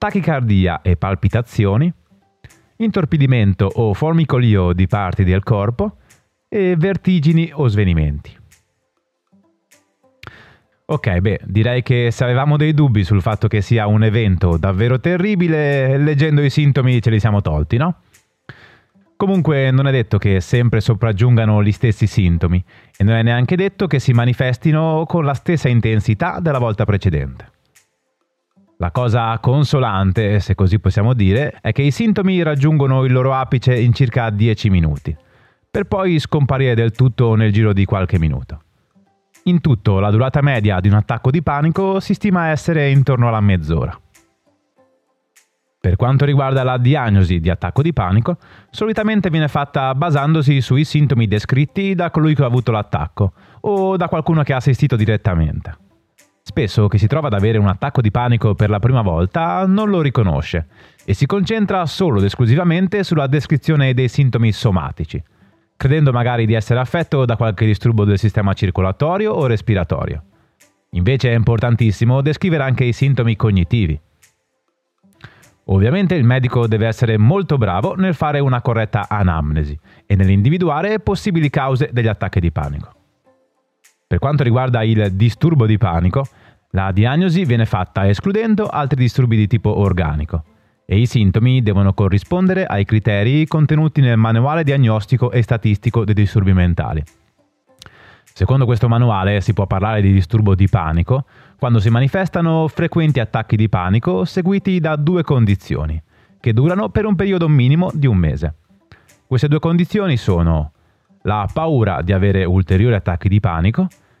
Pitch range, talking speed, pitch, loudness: 100-150 Hz, 150 wpm, 120 Hz, -16 LUFS